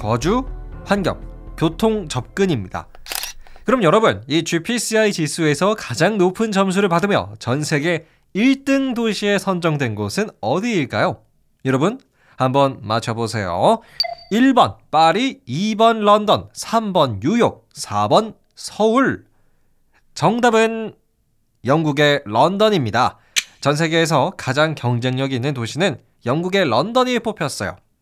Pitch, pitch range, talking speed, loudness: 165 Hz, 125-215 Hz, 235 characters per minute, -18 LUFS